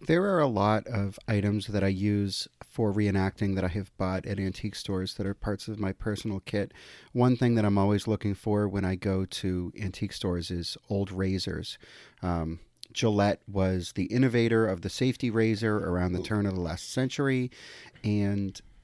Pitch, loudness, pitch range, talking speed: 100 Hz, -29 LUFS, 95-110 Hz, 185 wpm